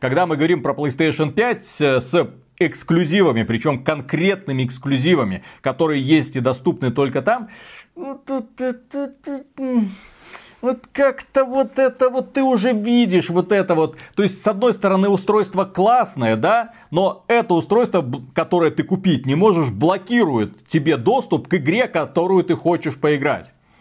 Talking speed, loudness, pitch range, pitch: 145 wpm, -19 LUFS, 155-235 Hz, 180 Hz